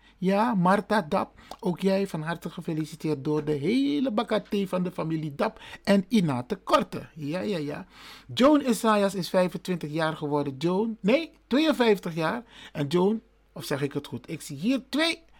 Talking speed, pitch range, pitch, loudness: 170 wpm, 160-220 Hz, 190 Hz, -27 LUFS